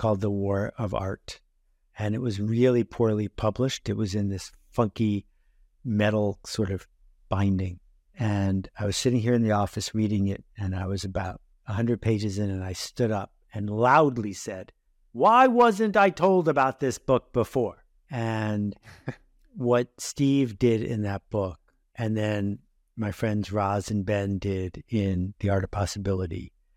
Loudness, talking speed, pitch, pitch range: -26 LUFS, 165 wpm, 105 Hz, 100-115 Hz